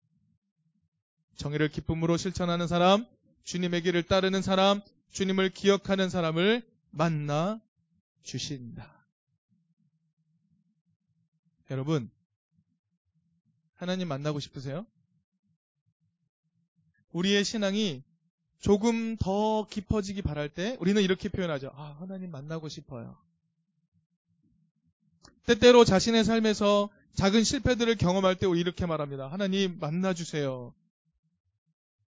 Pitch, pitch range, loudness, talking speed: 175 Hz, 160-195 Hz, -27 LUFS, 225 characters per minute